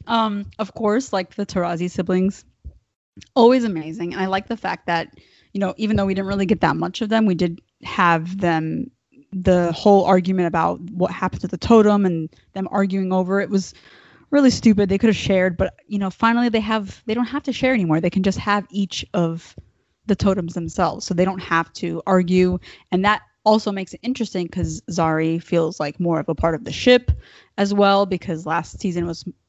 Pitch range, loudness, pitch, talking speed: 175-210 Hz, -20 LUFS, 190 Hz, 210 wpm